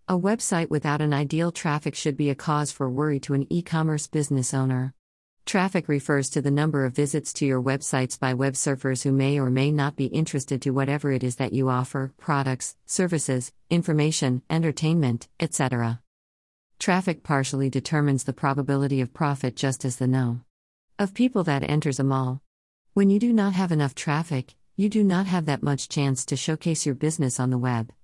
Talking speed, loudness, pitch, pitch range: 185 wpm, -25 LUFS, 140 Hz, 130-155 Hz